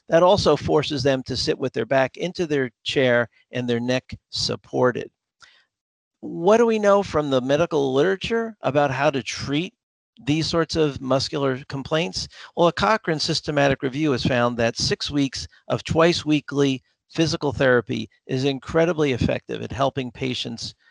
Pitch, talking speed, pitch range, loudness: 140 Hz, 155 wpm, 130-160 Hz, -22 LUFS